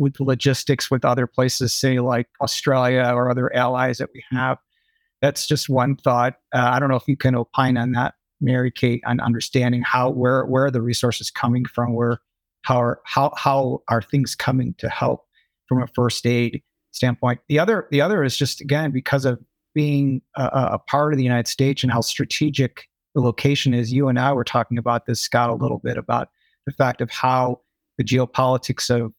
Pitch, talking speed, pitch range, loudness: 130 Hz, 200 wpm, 120-140 Hz, -21 LUFS